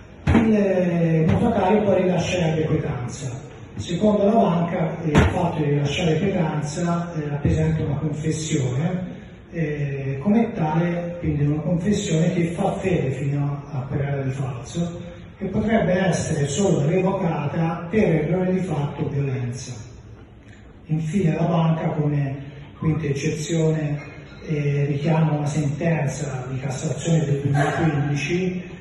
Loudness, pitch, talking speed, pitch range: -22 LUFS, 155 Hz, 115 wpm, 145-175 Hz